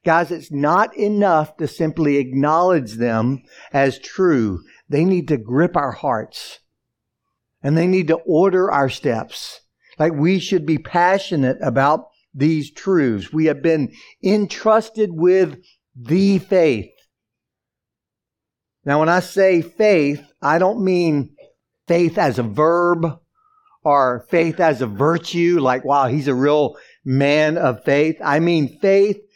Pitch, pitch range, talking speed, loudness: 160 Hz, 140-180 Hz, 135 wpm, -18 LUFS